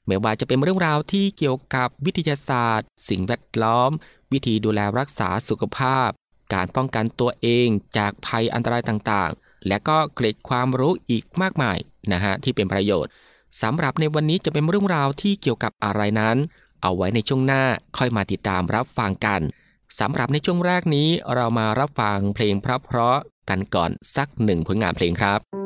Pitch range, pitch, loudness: 105-145 Hz, 120 Hz, -22 LUFS